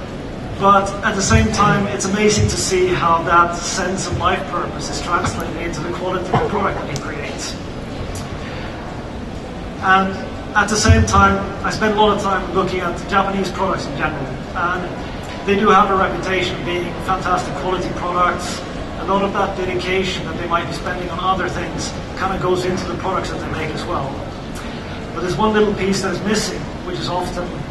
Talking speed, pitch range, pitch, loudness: 195 wpm, 175-195 Hz, 185 Hz, -18 LUFS